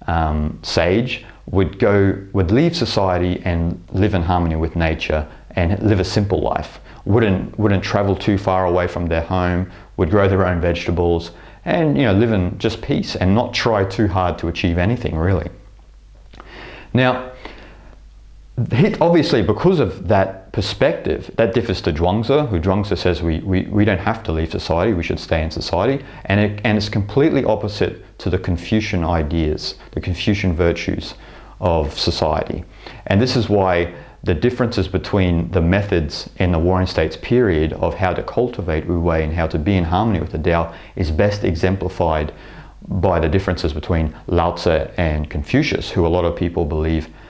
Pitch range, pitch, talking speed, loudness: 85-105 Hz, 90 Hz, 170 wpm, -19 LUFS